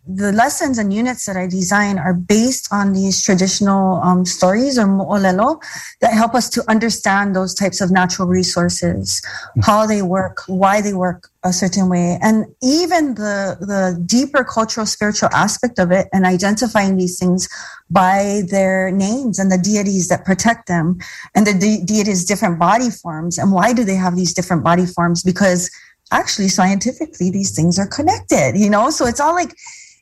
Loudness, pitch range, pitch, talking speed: -16 LUFS, 185-220 Hz, 195 Hz, 175 wpm